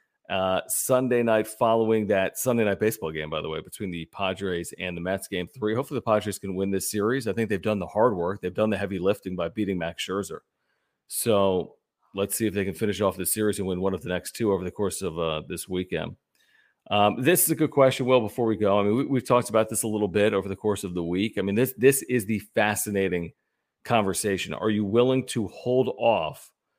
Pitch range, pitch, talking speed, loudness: 95-115 Hz, 105 Hz, 240 wpm, -25 LUFS